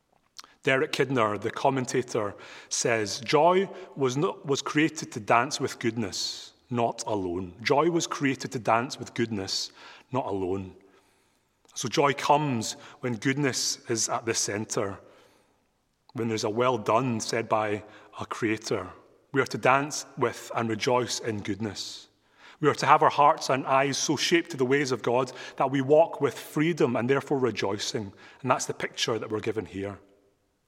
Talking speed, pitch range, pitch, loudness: 160 wpm, 110-140 Hz, 125 Hz, -27 LUFS